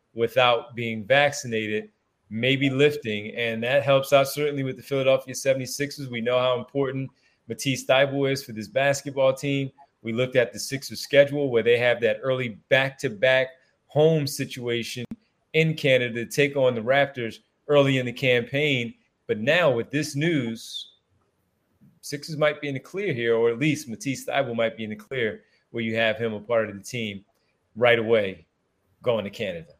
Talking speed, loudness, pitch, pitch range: 175 wpm, -24 LUFS, 130 Hz, 115-140 Hz